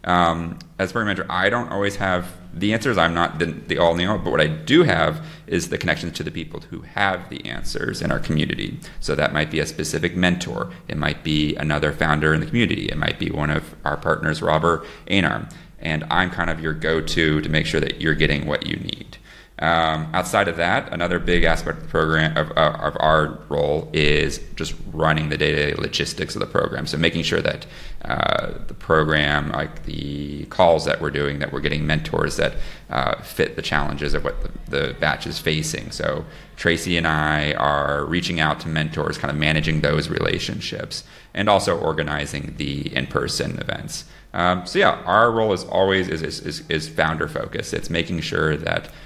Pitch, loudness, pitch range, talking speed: 80 Hz, -21 LUFS, 75-85 Hz, 200 wpm